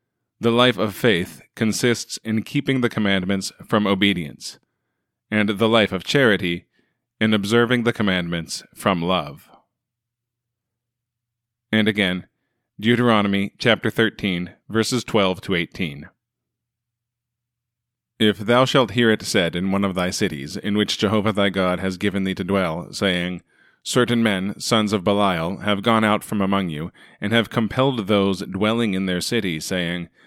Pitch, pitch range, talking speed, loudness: 105 Hz, 95-120 Hz, 145 wpm, -21 LUFS